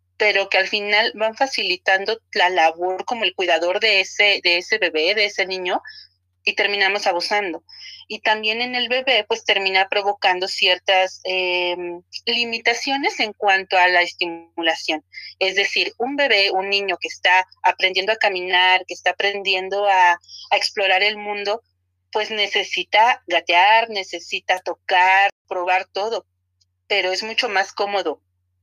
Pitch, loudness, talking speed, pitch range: 190 Hz, -18 LUFS, 145 wpm, 180-210 Hz